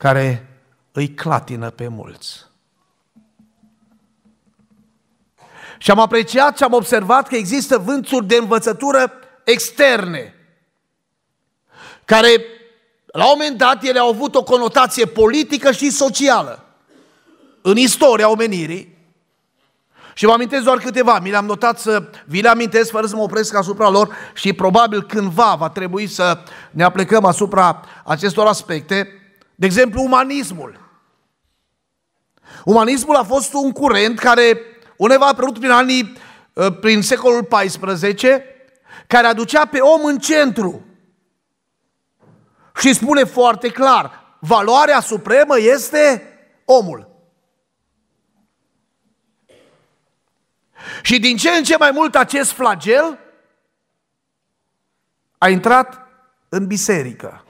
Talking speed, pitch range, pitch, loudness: 110 wpm, 200-265 Hz, 230 Hz, -14 LUFS